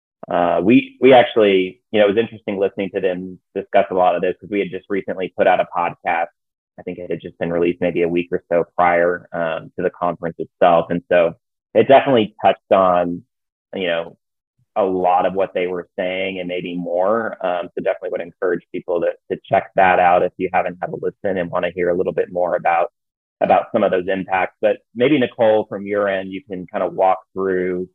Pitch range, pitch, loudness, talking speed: 90-105 Hz, 95 Hz, -18 LUFS, 225 wpm